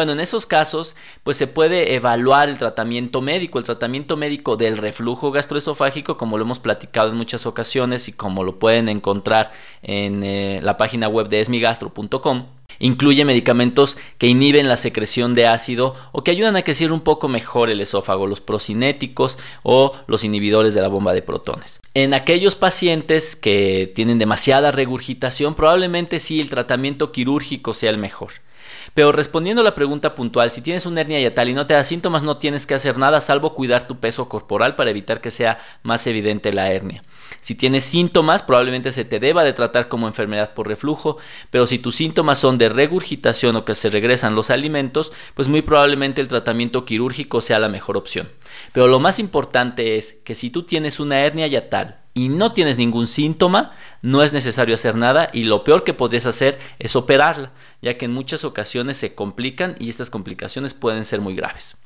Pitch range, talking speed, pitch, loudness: 115-145 Hz, 190 wpm, 125 Hz, -18 LUFS